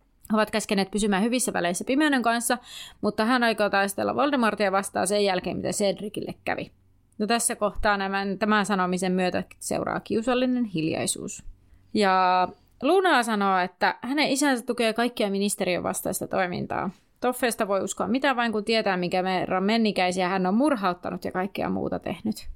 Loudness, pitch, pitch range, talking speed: -25 LUFS, 205 Hz, 185-235 Hz, 150 wpm